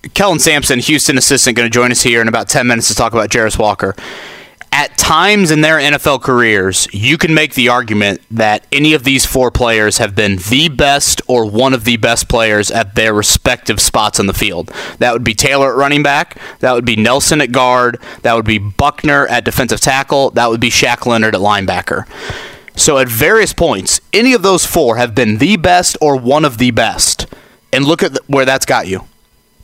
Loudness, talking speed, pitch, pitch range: -10 LUFS, 210 wpm, 125 Hz, 115-140 Hz